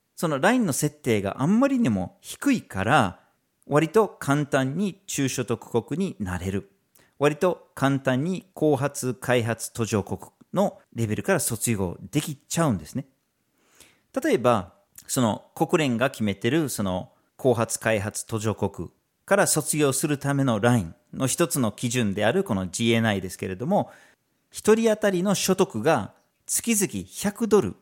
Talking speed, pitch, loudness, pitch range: 275 characters per minute, 130 Hz, -24 LUFS, 110-165 Hz